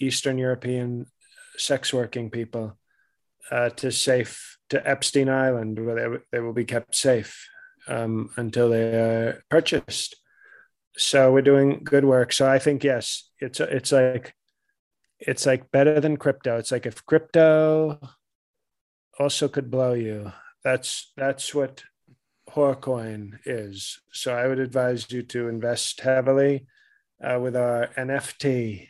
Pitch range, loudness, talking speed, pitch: 120-140 Hz, -23 LUFS, 135 wpm, 130 Hz